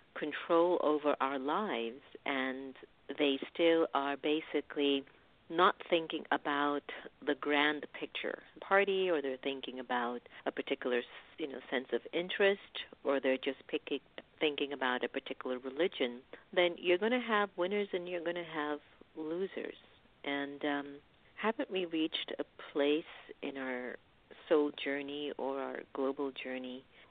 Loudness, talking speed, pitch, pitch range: -35 LUFS, 140 wpm, 145 Hz, 135-170 Hz